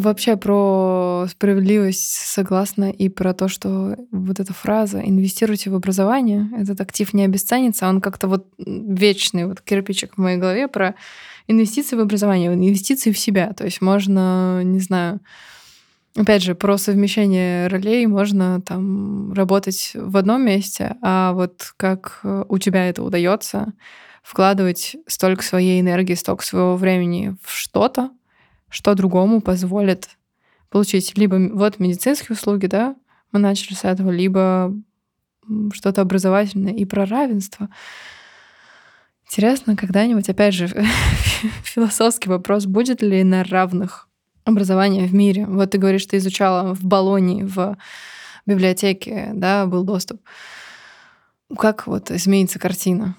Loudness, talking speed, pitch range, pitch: -18 LUFS, 130 wpm, 185-210 Hz, 195 Hz